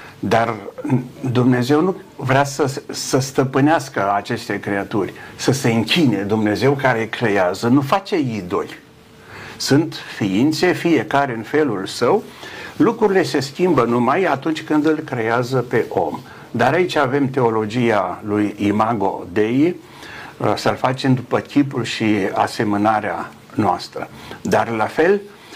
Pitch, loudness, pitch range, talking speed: 130 Hz, -18 LUFS, 110-150 Hz, 120 wpm